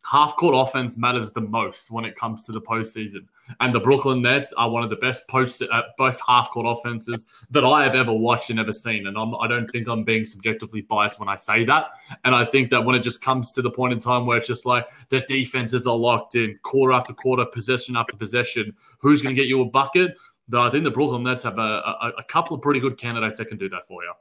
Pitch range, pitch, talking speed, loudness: 115-130 Hz, 120 Hz, 255 wpm, -21 LUFS